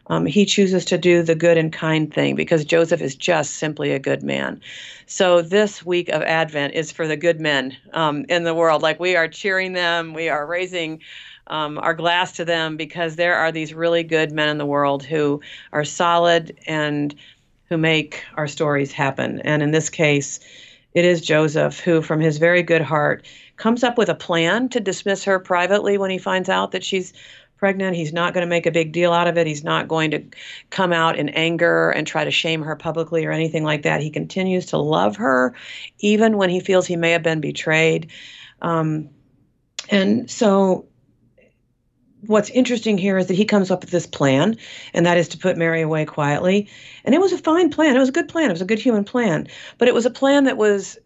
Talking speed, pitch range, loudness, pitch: 215 wpm, 155-190 Hz, -19 LUFS, 170 Hz